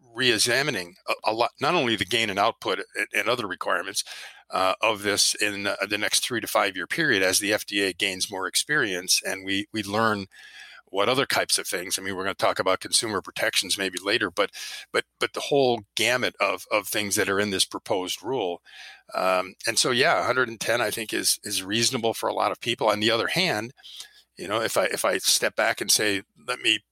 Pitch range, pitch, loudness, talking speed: 95-110 Hz, 100 Hz, -24 LUFS, 220 wpm